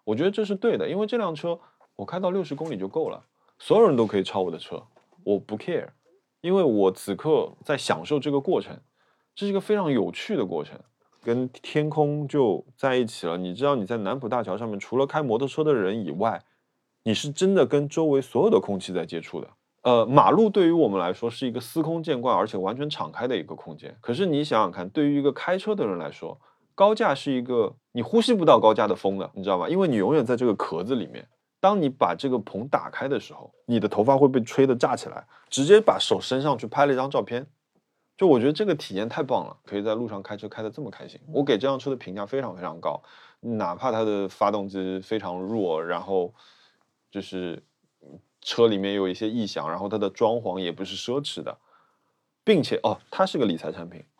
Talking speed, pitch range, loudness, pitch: 330 characters per minute, 100-150 Hz, -24 LUFS, 125 Hz